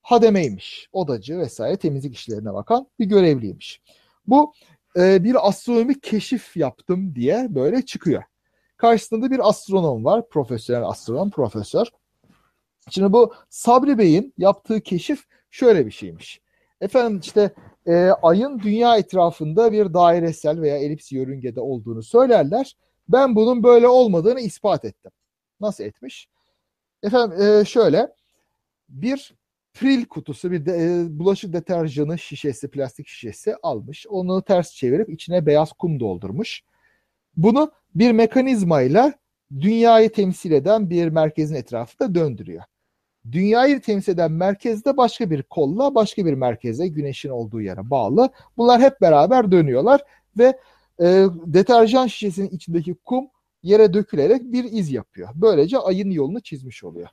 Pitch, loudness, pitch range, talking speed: 195 Hz, -19 LUFS, 155-235 Hz, 125 wpm